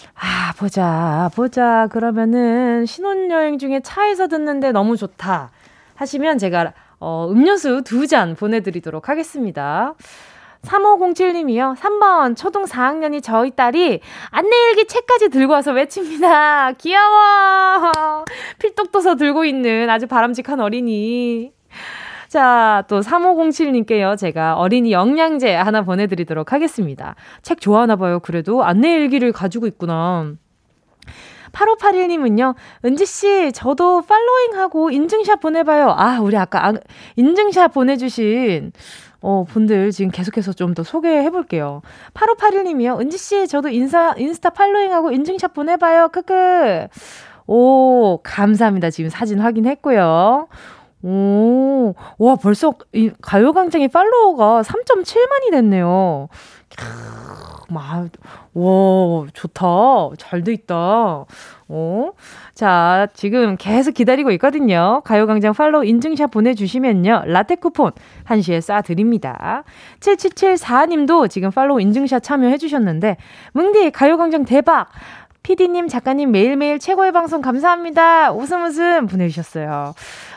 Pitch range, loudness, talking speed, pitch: 205-330 Hz, -15 LUFS, 270 characters per minute, 255 Hz